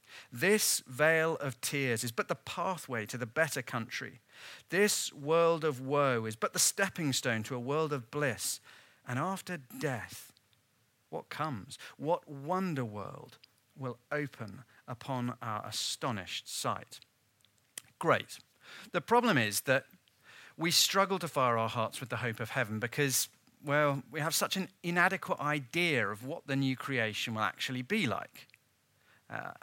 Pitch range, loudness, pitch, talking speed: 120-165 Hz, -32 LUFS, 135 Hz, 150 wpm